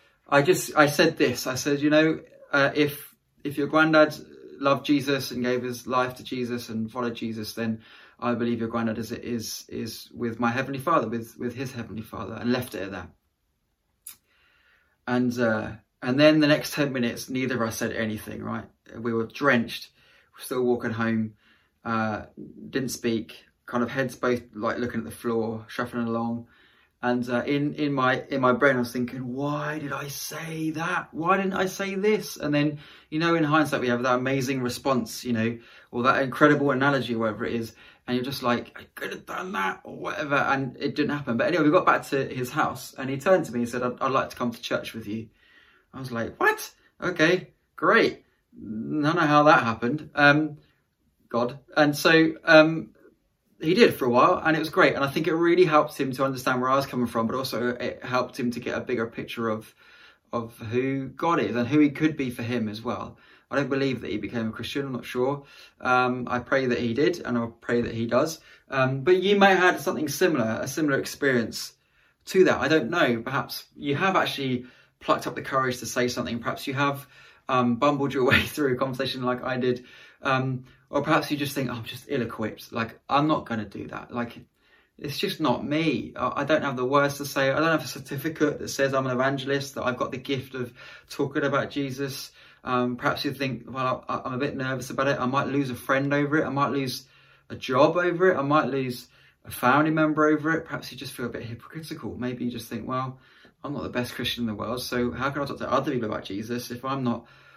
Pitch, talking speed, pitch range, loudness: 130 Hz, 225 wpm, 120-145 Hz, -25 LUFS